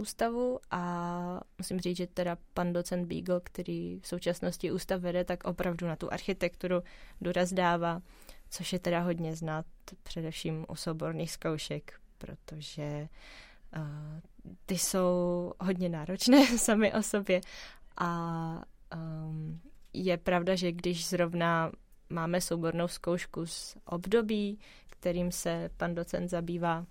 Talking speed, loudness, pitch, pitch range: 125 wpm, -33 LUFS, 175 Hz, 165-185 Hz